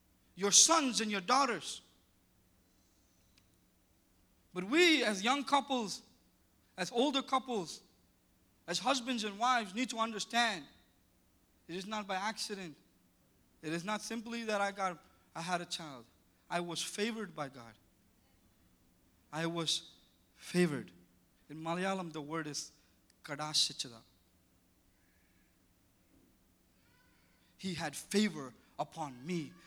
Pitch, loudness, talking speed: 165 Hz, -34 LUFS, 110 wpm